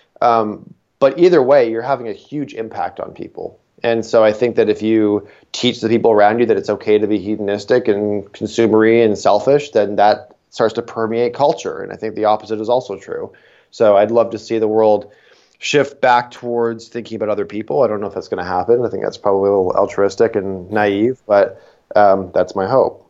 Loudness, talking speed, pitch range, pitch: -16 LUFS, 215 wpm, 105-120 Hz, 110 Hz